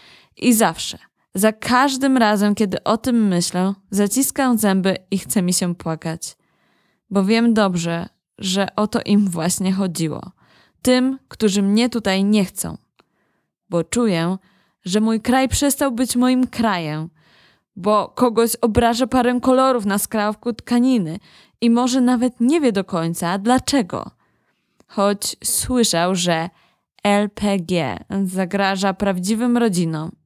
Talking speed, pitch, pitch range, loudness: 125 wpm, 205 Hz, 185-240 Hz, -19 LUFS